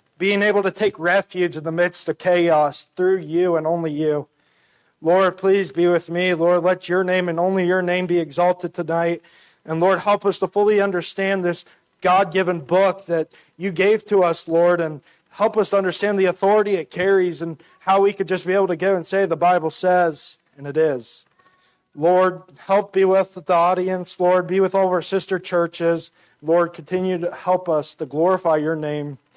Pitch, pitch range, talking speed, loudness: 180 Hz, 170-190 Hz, 200 wpm, -19 LUFS